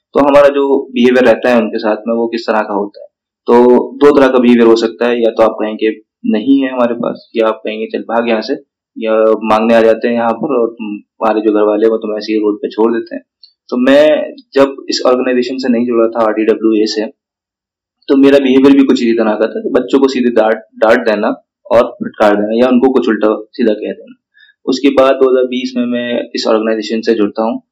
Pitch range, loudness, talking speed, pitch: 110-130 Hz, -11 LUFS, 230 wpm, 115 Hz